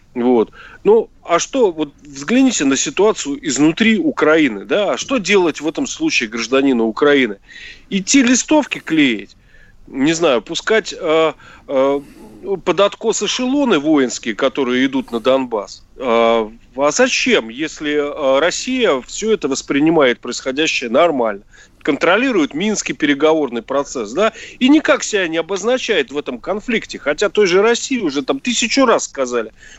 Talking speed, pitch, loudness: 135 wpm, 190 Hz, -16 LUFS